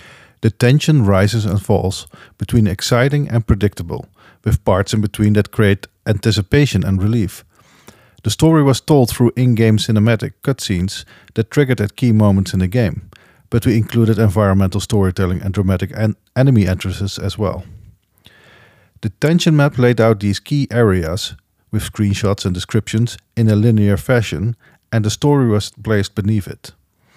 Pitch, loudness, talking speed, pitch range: 110 Hz, -16 LUFS, 150 wpm, 100-120 Hz